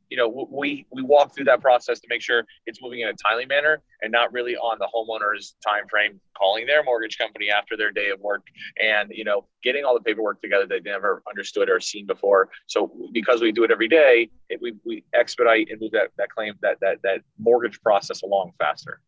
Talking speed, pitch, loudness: 225 wpm, 140 Hz, -22 LUFS